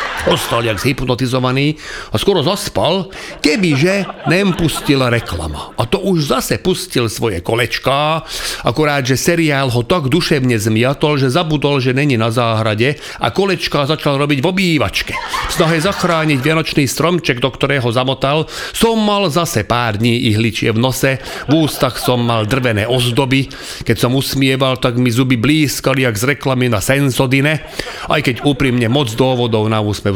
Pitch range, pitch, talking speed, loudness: 120-155 Hz, 135 Hz, 155 wpm, -15 LUFS